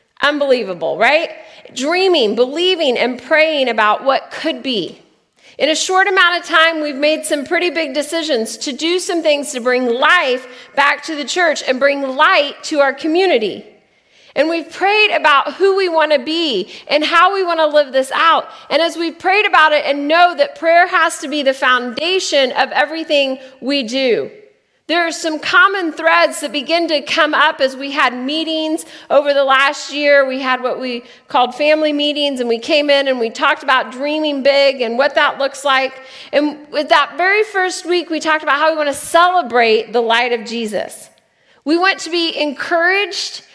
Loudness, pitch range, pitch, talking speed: -14 LUFS, 270-330 Hz, 295 Hz, 190 wpm